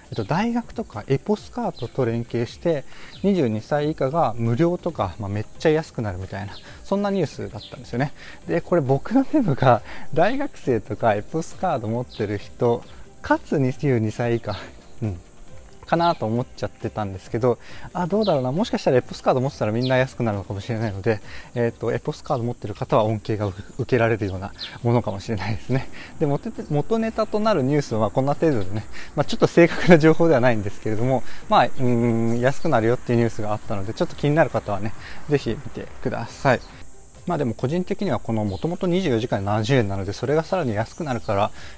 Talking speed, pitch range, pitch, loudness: 425 characters per minute, 110-160 Hz, 125 Hz, -23 LUFS